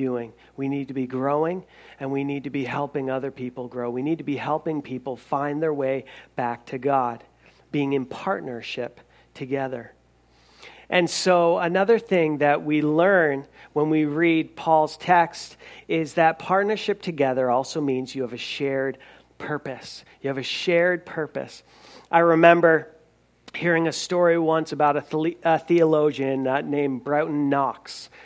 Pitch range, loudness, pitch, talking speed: 135-165 Hz, -23 LUFS, 145 Hz, 150 wpm